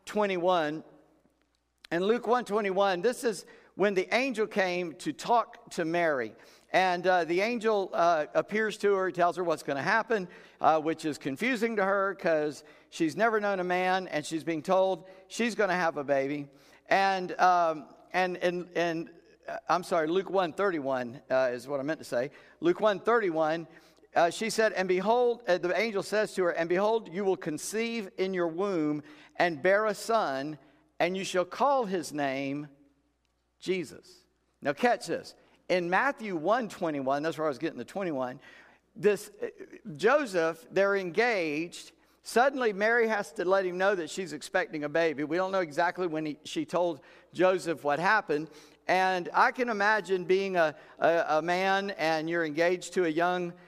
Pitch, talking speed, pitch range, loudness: 180 Hz, 175 wpm, 160-200 Hz, -29 LUFS